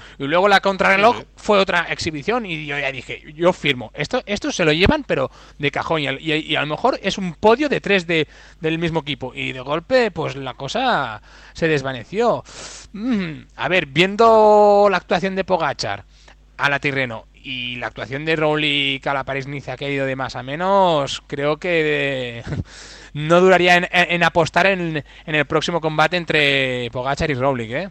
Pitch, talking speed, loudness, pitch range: 155 Hz, 195 wpm, -18 LUFS, 135-185 Hz